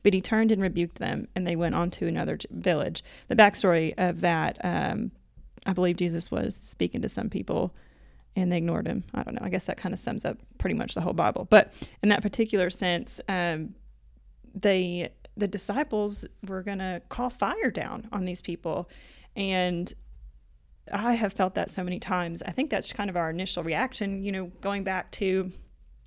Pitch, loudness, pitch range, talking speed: 185 Hz, -28 LUFS, 175-205 Hz, 195 wpm